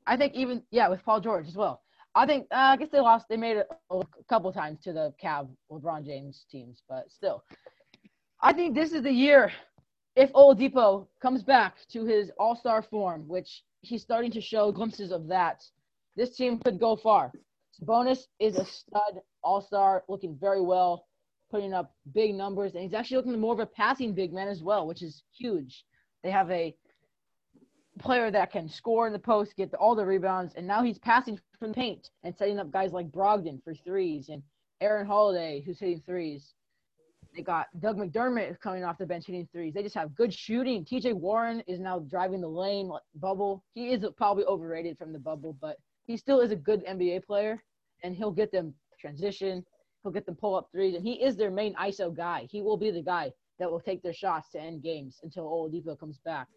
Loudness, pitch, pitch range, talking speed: -28 LUFS, 200 Hz, 175-225 Hz, 210 wpm